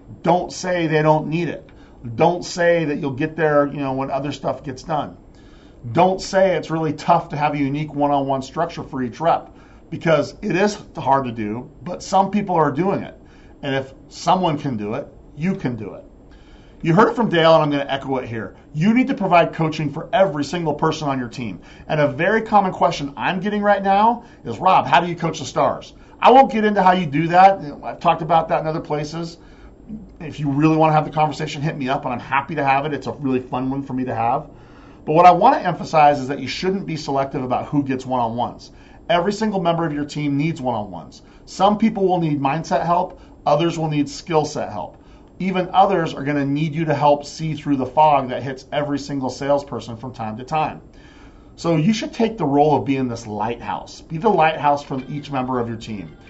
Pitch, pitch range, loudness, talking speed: 150 Hz, 135-170 Hz, -19 LUFS, 230 wpm